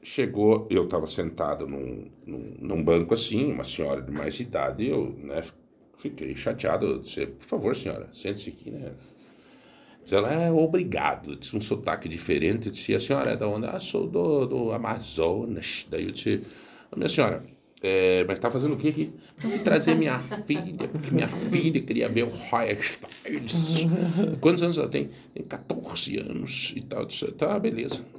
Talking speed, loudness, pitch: 185 wpm, -27 LUFS, 110 Hz